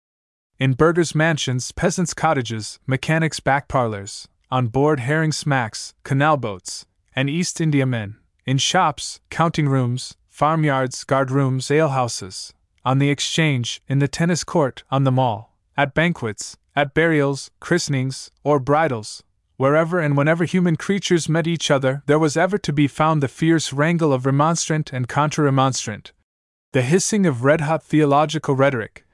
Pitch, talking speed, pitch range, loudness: 140 Hz, 145 wpm, 130-160 Hz, -20 LUFS